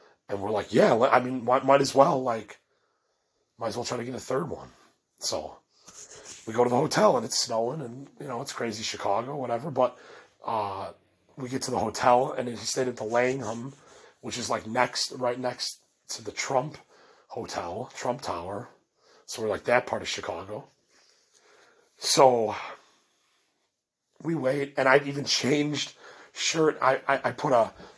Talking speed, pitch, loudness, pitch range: 170 wpm, 130 Hz, -27 LUFS, 120-140 Hz